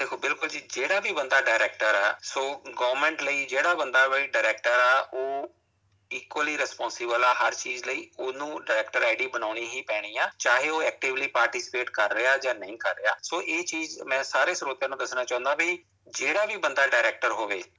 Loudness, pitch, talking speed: -26 LUFS, 140 Hz, 185 wpm